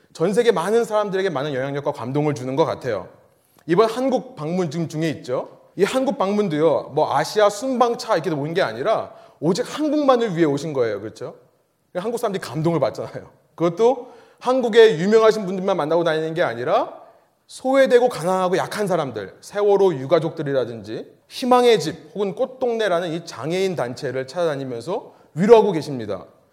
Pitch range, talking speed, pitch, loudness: 155-235 Hz, 385 characters per minute, 190 Hz, -20 LUFS